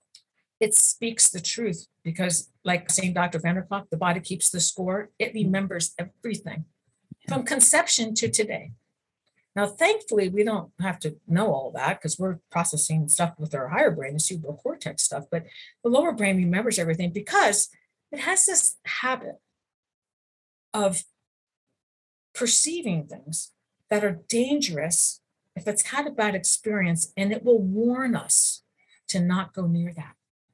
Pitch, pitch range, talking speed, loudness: 190 Hz, 170-220 Hz, 145 wpm, -23 LUFS